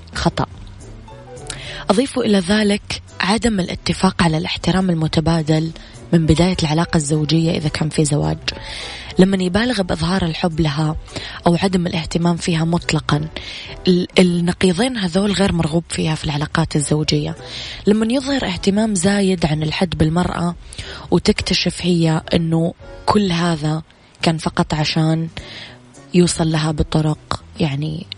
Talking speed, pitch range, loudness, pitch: 115 wpm, 155-185 Hz, -18 LUFS, 165 Hz